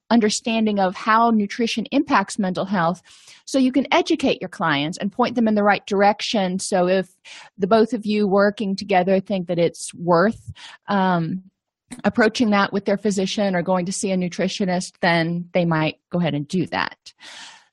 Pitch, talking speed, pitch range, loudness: 200 Hz, 175 wpm, 180-220 Hz, -20 LUFS